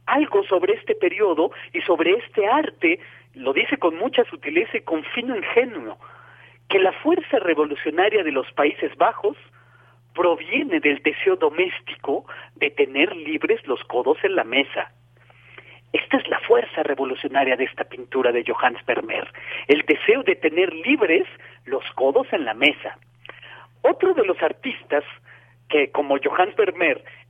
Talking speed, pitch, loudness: 145 wpm, 290 Hz, -21 LUFS